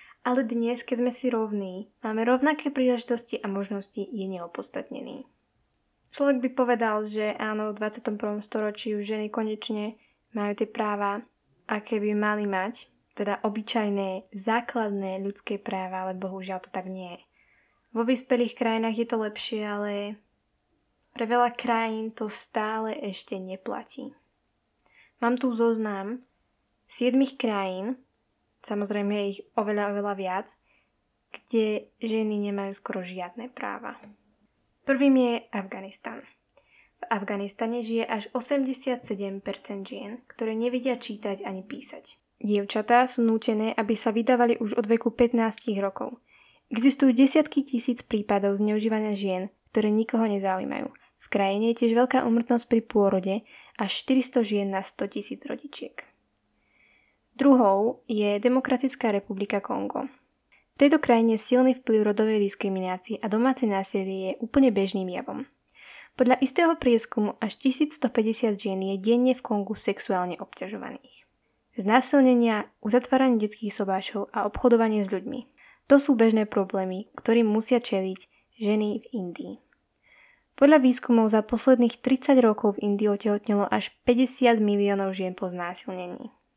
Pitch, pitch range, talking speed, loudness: 220 Hz, 205-245 Hz, 130 wpm, -26 LUFS